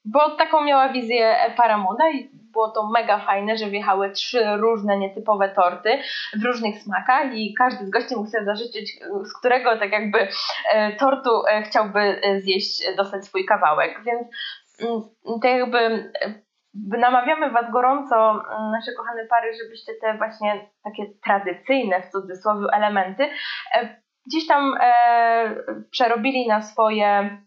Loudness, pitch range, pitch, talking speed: -21 LUFS, 210-250 Hz, 225 Hz, 140 wpm